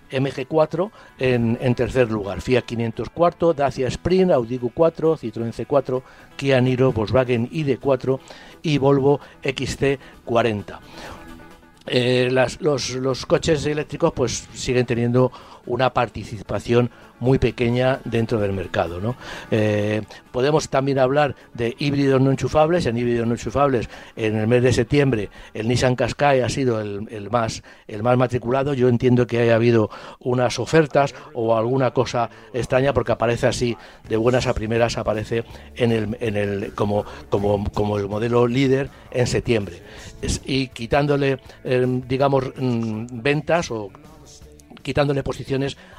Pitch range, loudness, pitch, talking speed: 115-135 Hz, -21 LUFS, 125 Hz, 135 wpm